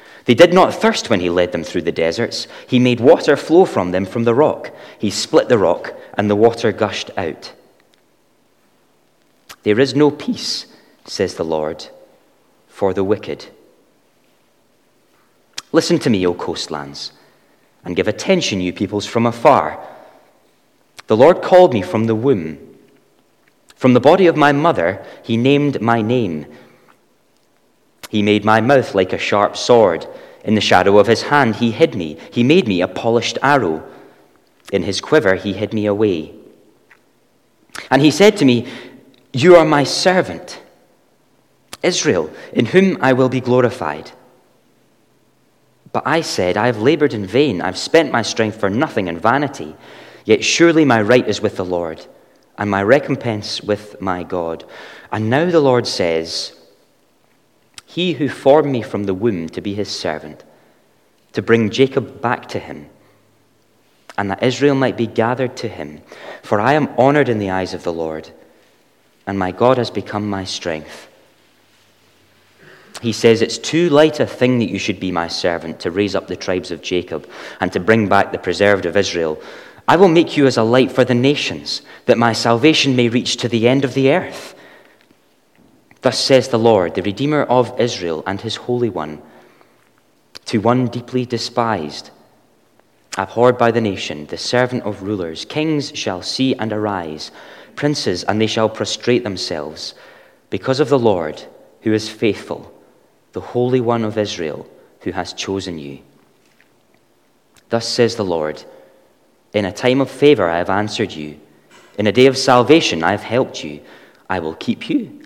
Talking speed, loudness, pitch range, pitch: 165 wpm, -16 LUFS, 100-130 Hz, 115 Hz